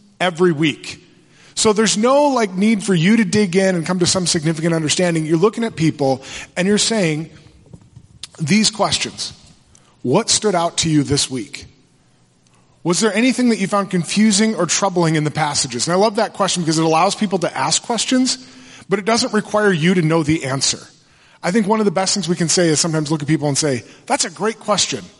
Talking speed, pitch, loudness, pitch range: 210 wpm, 180 Hz, -17 LUFS, 155-210 Hz